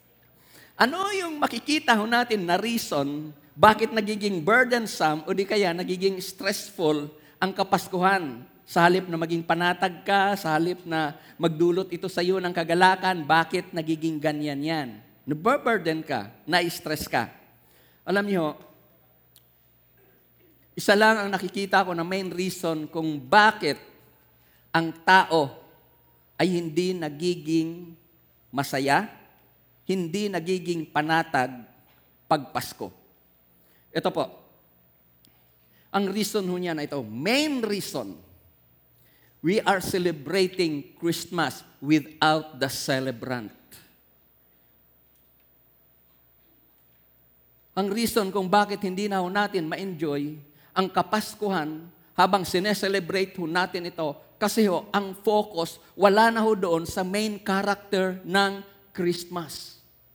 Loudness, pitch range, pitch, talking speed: -25 LUFS, 155-195 Hz, 175 Hz, 110 wpm